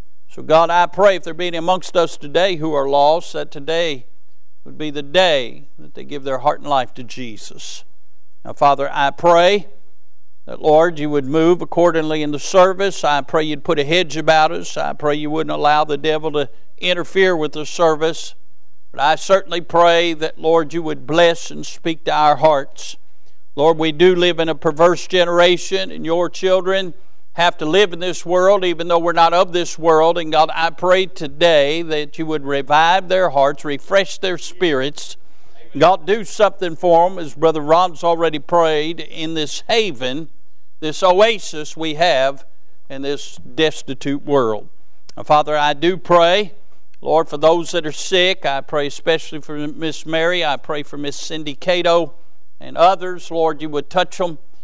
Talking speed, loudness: 180 wpm, -16 LUFS